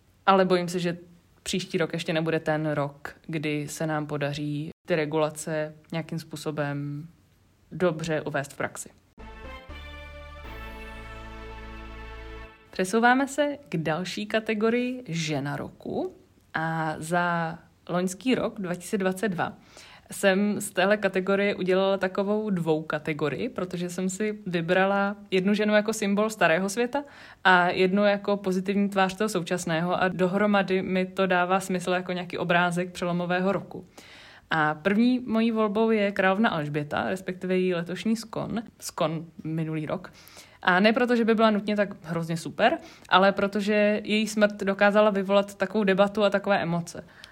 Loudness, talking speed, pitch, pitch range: -26 LUFS, 135 wpm, 185 Hz, 160-205 Hz